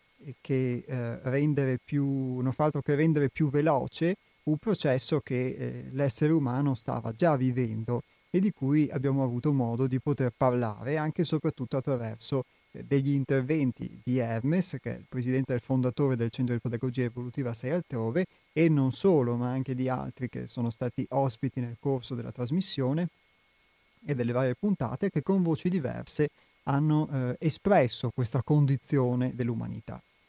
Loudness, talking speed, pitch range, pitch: -29 LUFS, 155 wpm, 125-150 Hz, 130 Hz